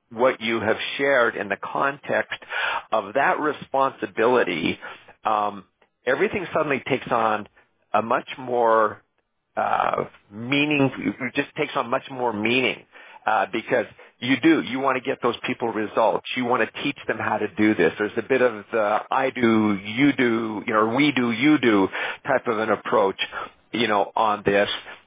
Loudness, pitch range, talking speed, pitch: -23 LUFS, 110-135 Hz, 170 wpm, 120 Hz